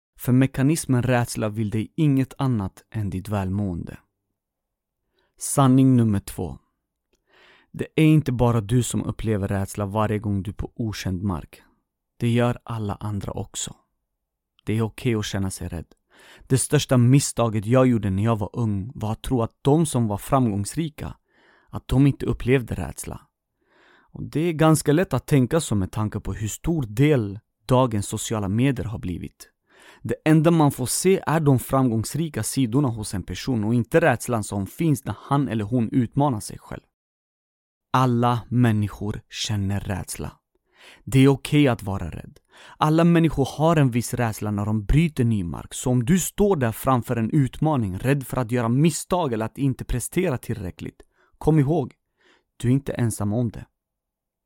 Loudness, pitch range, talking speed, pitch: -23 LUFS, 105-135 Hz, 170 wpm, 120 Hz